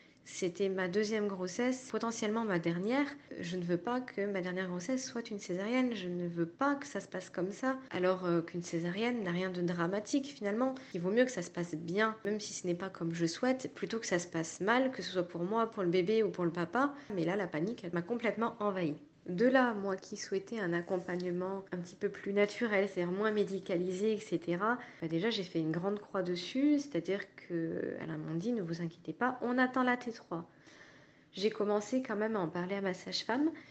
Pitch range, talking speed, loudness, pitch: 175-230 Hz, 230 wpm, -35 LUFS, 195 Hz